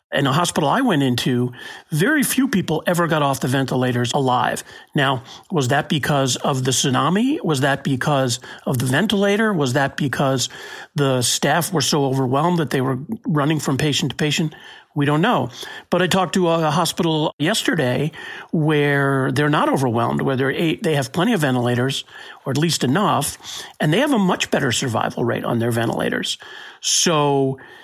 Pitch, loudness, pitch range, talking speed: 145 Hz, -19 LUFS, 135-165 Hz, 175 wpm